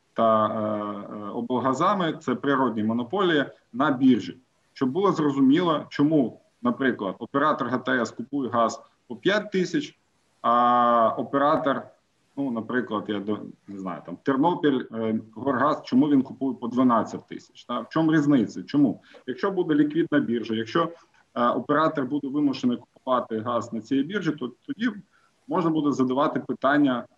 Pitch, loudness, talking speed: 135 Hz, -24 LUFS, 140 wpm